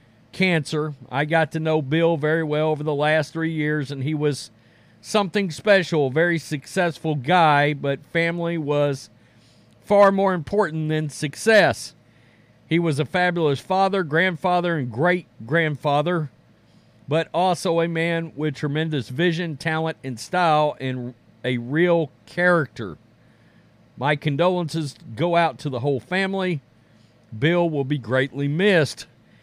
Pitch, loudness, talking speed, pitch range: 155 Hz, -22 LUFS, 135 wpm, 140-170 Hz